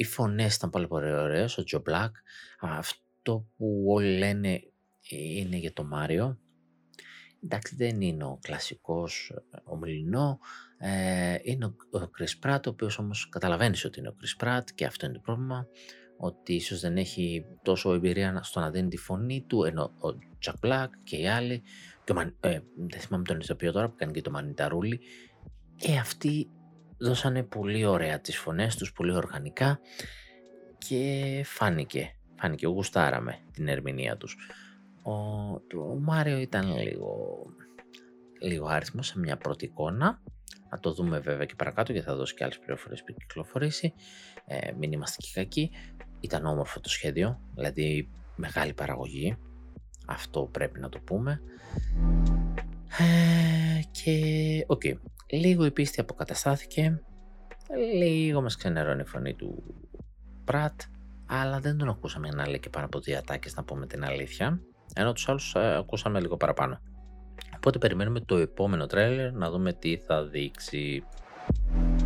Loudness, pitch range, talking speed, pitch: -30 LUFS, 75-125 Hz, 150 wpm, 95 Hz